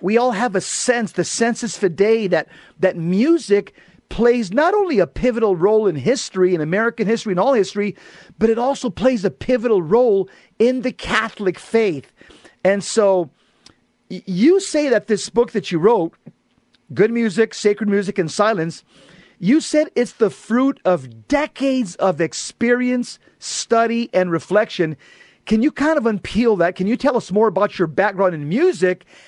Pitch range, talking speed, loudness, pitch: 185-245 Hz, 165 wpm, -18 LUFS, 215 Hz